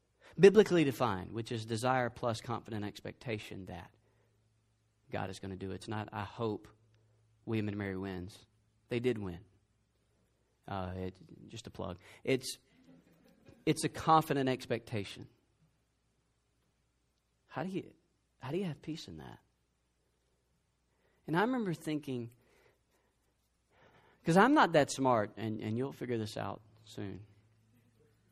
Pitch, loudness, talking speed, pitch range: 110 Hz, -34 LUFS, 130 wpm, 100-125 Hz